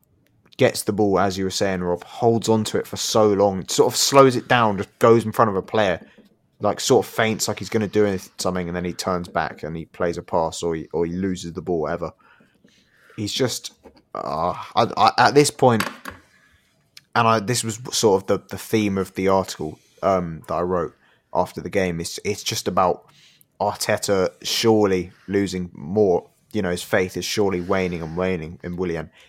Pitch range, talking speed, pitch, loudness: 90-110 Hz, 205 wpm, 95 Hz, -21 LUFS